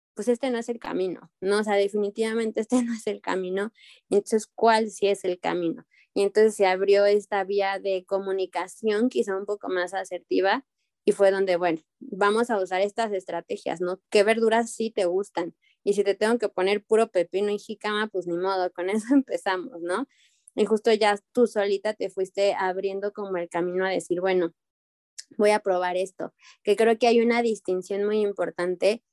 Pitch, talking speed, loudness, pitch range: 200 Hz, 190 wpm, -25 LUFS, 185-220 Hz